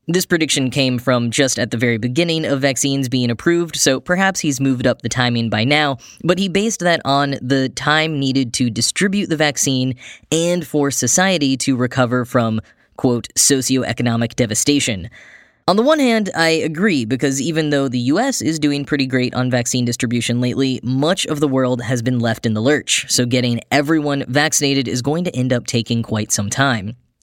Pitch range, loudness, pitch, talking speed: 125-150 Hz, -17 LUFS, 135 Hz, 185 wpm